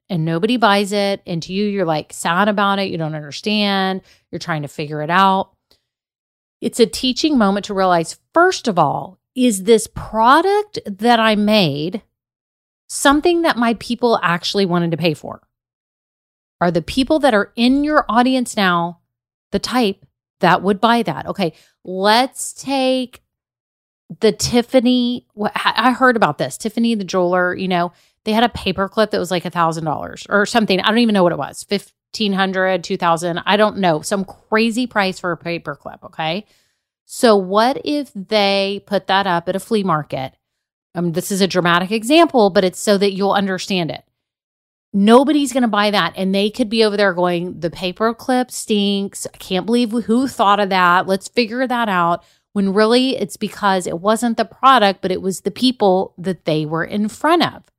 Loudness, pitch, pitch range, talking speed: -17 LUFS, 200 Hz, 180-230 Hz, 180 wpm